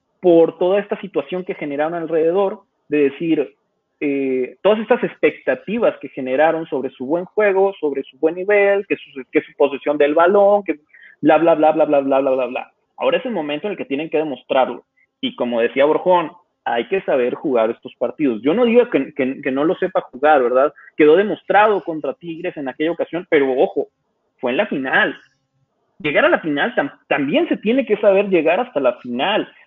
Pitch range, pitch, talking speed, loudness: 145-200 Hz, 165 Hz, 200 wpm, -18 LUFS